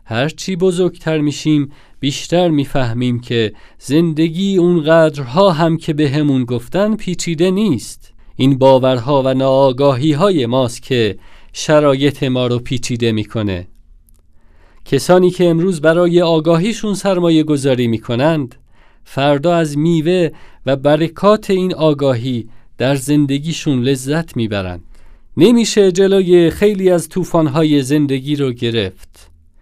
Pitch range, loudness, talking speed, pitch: 125-170 Hz, -14 LUFS, 110 wpm, 145 Hz